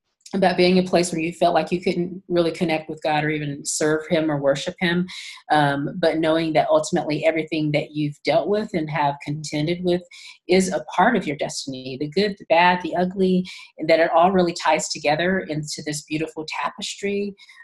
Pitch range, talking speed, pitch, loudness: 155-180 Hz, 200 wpm, 165 Hz, -22 LUFS